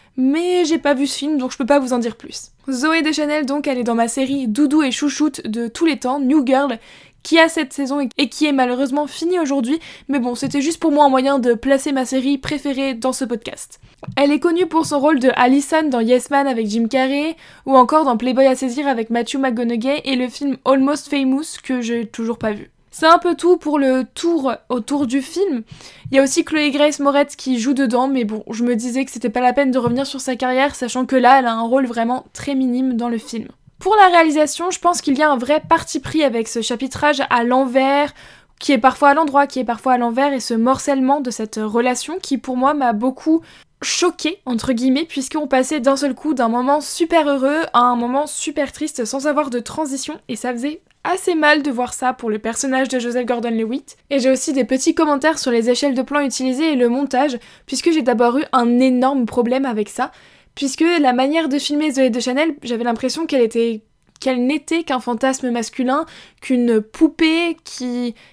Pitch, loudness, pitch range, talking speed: 270 Hz, -17 LUFS, 250-295 Hz, 225 wpm